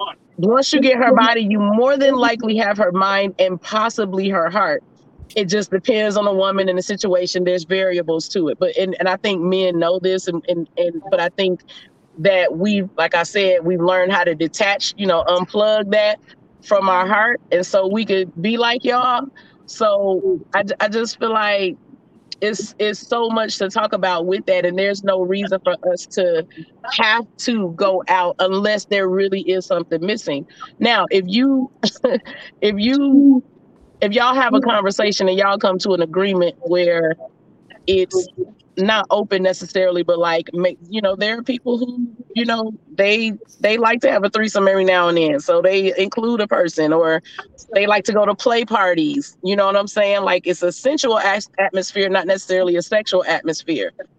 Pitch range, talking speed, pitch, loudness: 185-225 Hz, 190 wpm, 195 Hz, -17 LUFS